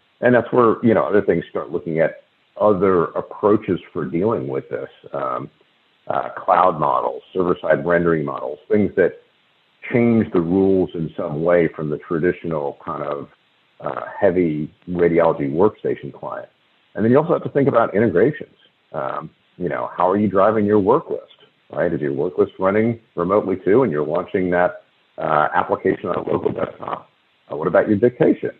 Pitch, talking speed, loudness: 105 Hz, 170 wpm, -19 LUFS